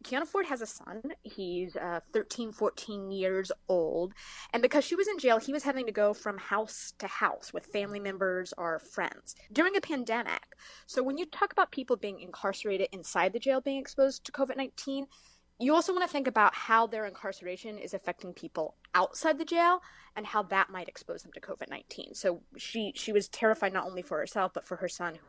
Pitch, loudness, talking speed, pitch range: 220 Hz, -32 LUFS, 200 wpm, 190-275 Hz